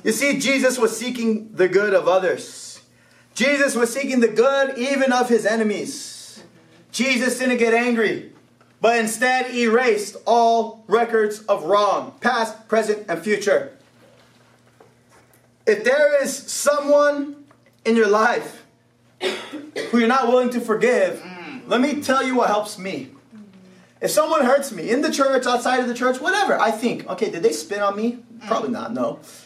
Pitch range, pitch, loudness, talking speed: 220-270 Hz, 240 Hz, -20 LUFS, 155 wpm